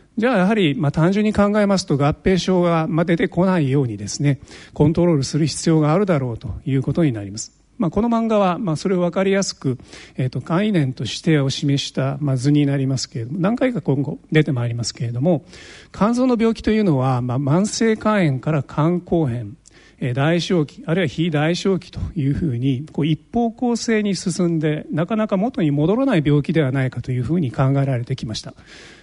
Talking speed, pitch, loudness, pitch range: 405 characters per minute, 155 Hz, -19 LUFS, 135-185 Hz